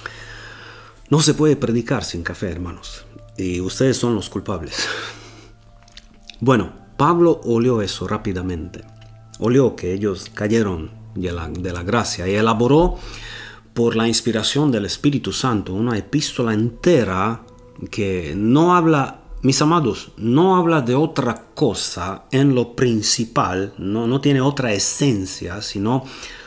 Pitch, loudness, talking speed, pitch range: 115 Hz, -19 LUFS, 120 wpm, 100-130 Hz